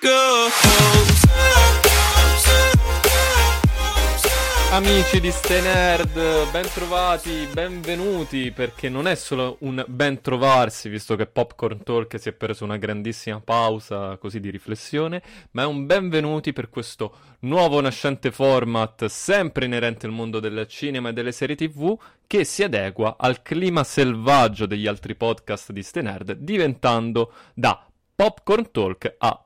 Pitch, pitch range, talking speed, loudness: 130 Hz, 110-160 Hz, 120 wpm, -20 LUFS